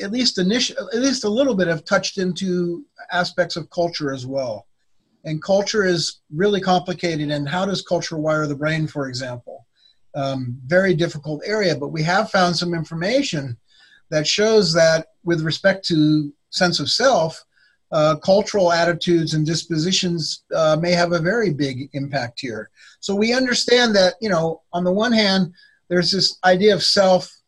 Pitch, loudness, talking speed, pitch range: 175 Hz, -19 LUFS, 170 wpm, 155-195 Hz